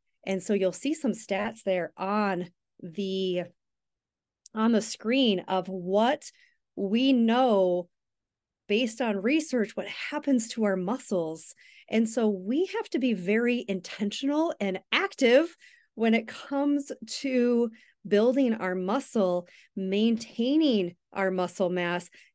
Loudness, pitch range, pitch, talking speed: -27 LUFS, 190-255 Hz, 220 Hz, 120 wpm